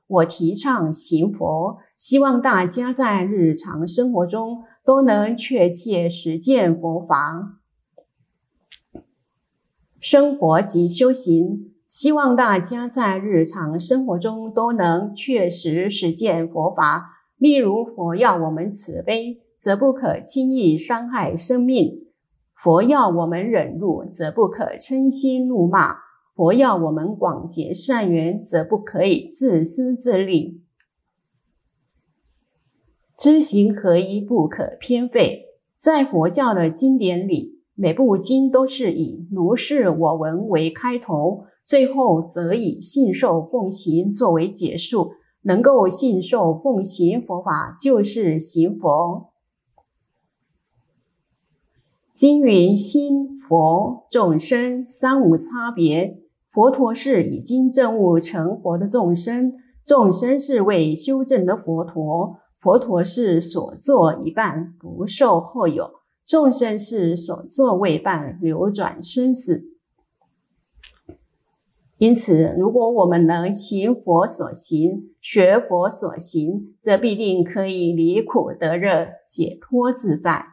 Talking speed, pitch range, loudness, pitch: 170 characters per minute, 170-250 Hz, -19 LUFS, 195 Hz